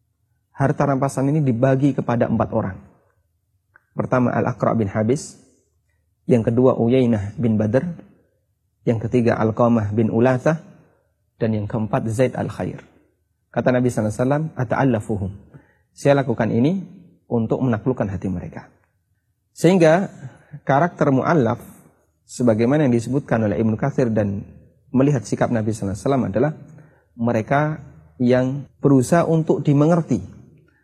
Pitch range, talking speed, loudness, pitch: 110-140 Hz, 115 wpm, -20 LUFS, 125 Hz